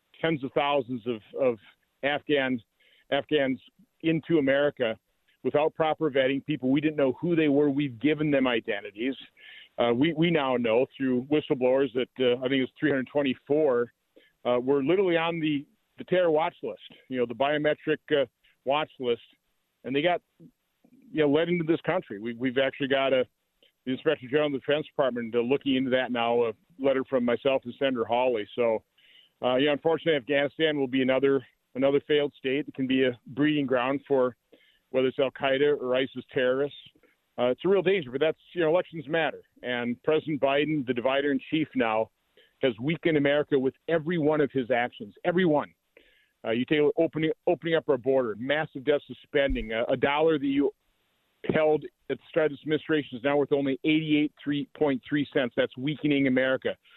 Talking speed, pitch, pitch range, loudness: 180 wpm, 140 Hz, 130-155 Hz, -27 LUFS